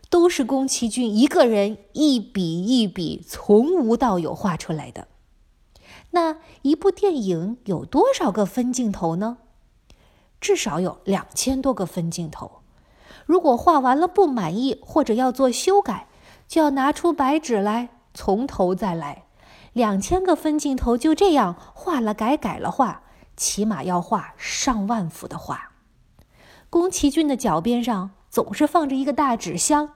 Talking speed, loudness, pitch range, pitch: 215 characters per minute, -21 LUFS, 205-300 Hz, 250 Hz